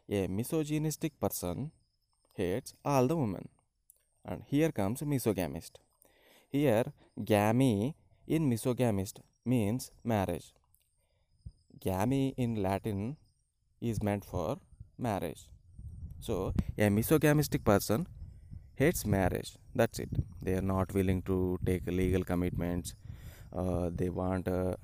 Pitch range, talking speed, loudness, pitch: 90-125 Hz, 105 wpm, -33 LUFS, 100 Hz